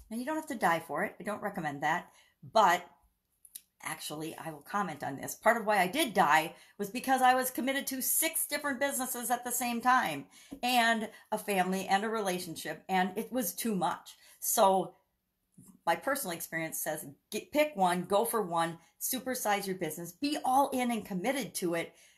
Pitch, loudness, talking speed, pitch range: 215 Hz, -31 LUFS, 190 wpm, 175-255 Hz